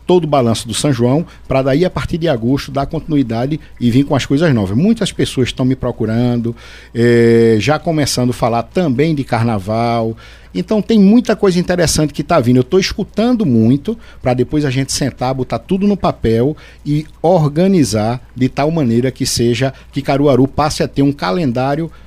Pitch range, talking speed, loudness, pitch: 120-155 Hz, 185 wpm, -14 LUFS, 135 Hz